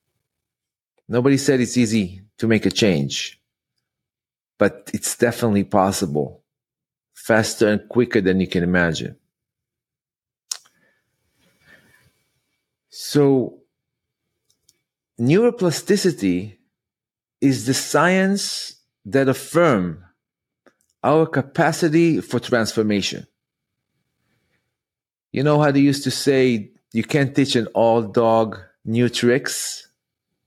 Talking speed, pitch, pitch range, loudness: 90 wpm, 120 Hz, 100-140 Hz, -19 LUFS